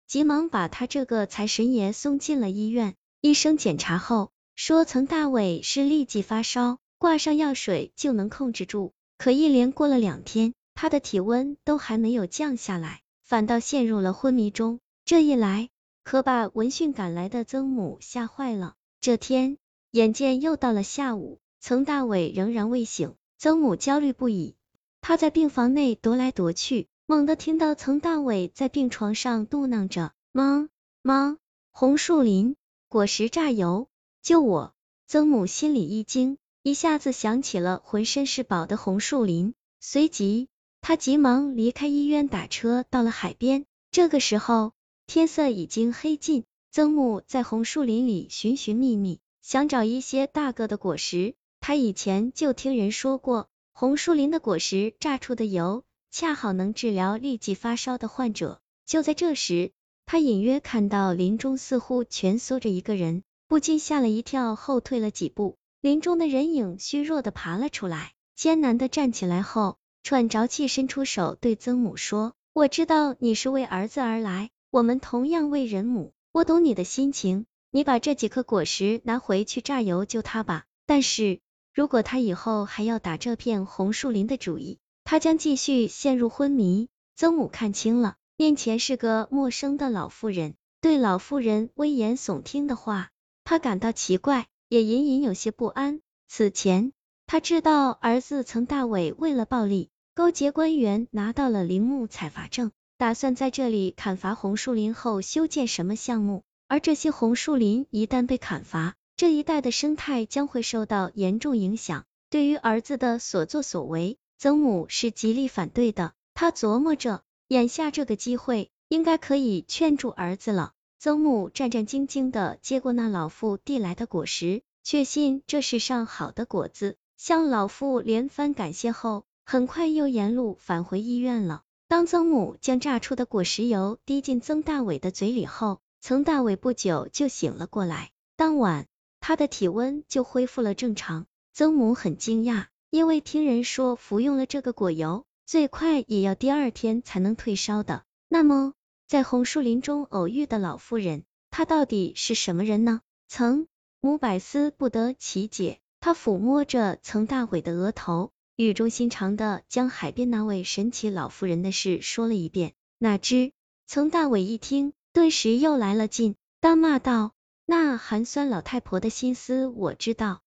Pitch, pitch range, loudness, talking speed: 240 Hz, 210-280 Hz, -25 LUFS, 245 characters per minute